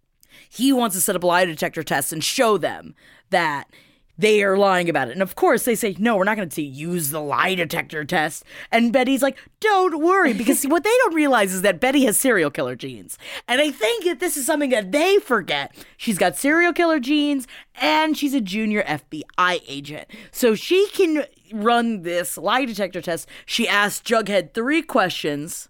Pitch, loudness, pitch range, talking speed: 225 Hz, -20 LUFS, 180-290 Hz, 195 wpm